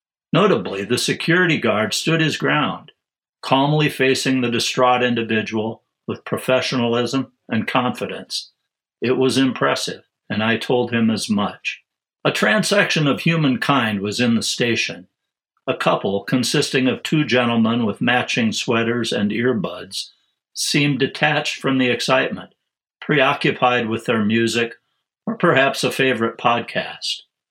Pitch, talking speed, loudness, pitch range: 125 Hz, 125 wpm, -19 LUFS, 115-145 Hz